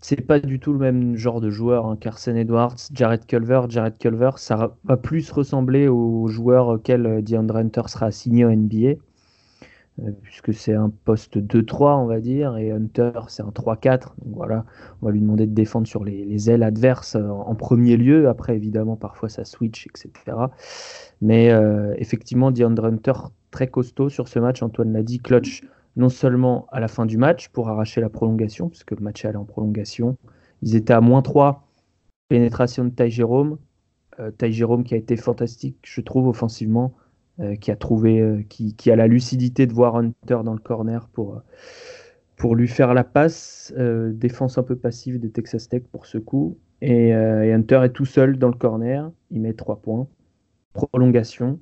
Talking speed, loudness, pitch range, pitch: 190 wpm, -20 LUFS, 110-125 Hz, 120 Hz